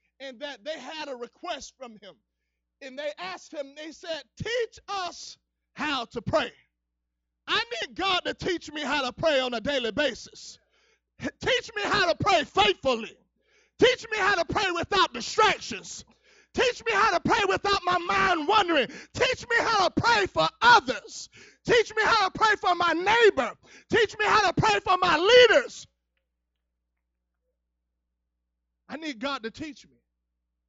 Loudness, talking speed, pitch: -24 LUFS, 160 wpm, 320 Hz